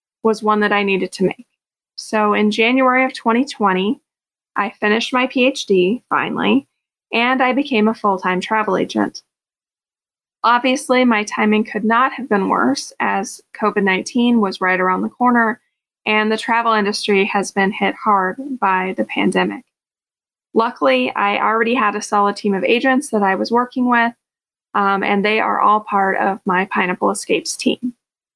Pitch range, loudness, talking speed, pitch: 200-245 Hz, -17 LUFS, 165 wpm, 215 Hz